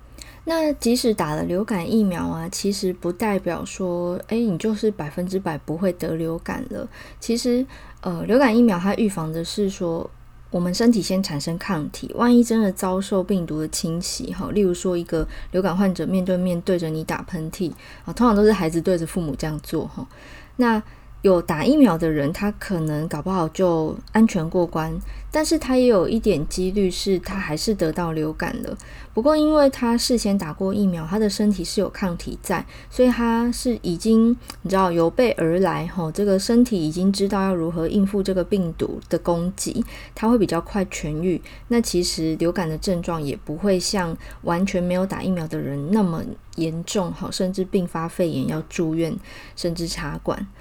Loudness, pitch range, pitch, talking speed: -22 LUFS, 165-210 Hz, 185 Hz, 280 characters per minute